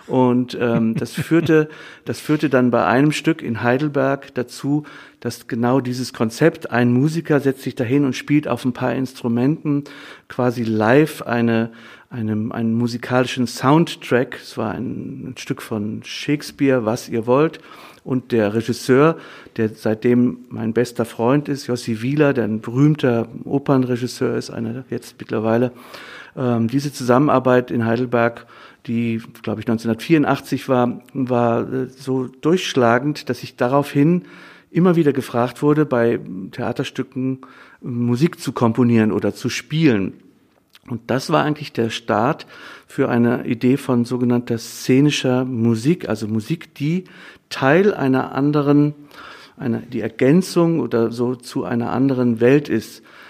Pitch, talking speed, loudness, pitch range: 125 Hz, 135 wpm, -19 LUFS, 120-145 Hz